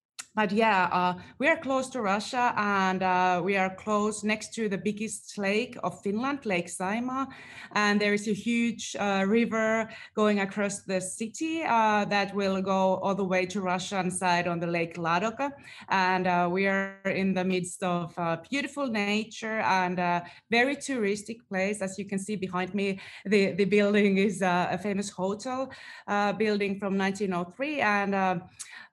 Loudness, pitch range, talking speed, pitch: -28 LUFS, 185-220 Hz, 170 wpm, 200 Hz